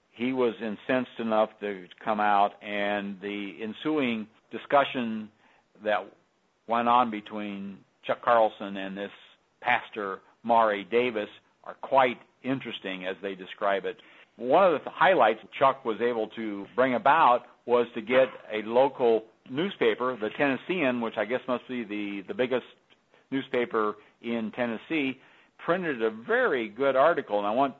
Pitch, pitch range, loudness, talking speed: 115 Hz, 105-125 Hz, -27 LUFS, 140 wpm